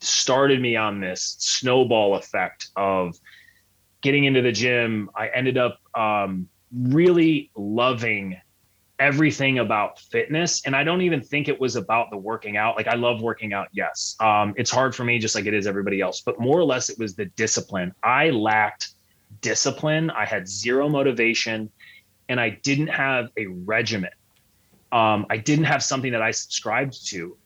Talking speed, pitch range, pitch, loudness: 170 wpm, 105-135 Hz, 115 Hz, -22 LUFS